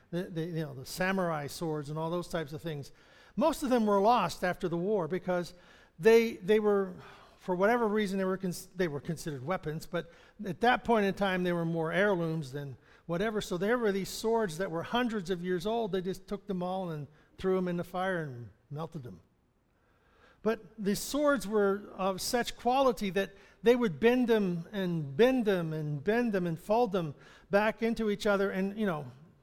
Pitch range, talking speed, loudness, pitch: 170-215 Hz, 205 wpm, -31 LUFS, 190 Hz